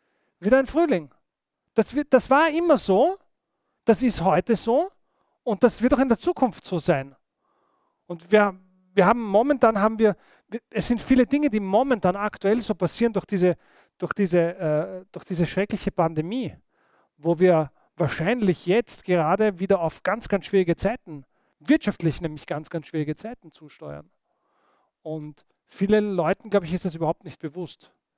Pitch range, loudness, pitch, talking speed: 170-230 Hz, -23 LUFS, 195 Hz, 160 wpm